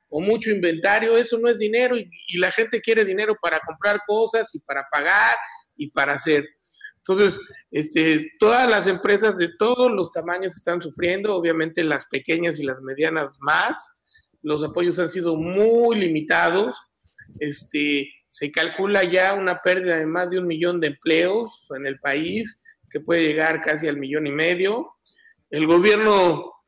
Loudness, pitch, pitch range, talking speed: -21 LUFS, 175 Hz, 160-215 Hz, 160 wpm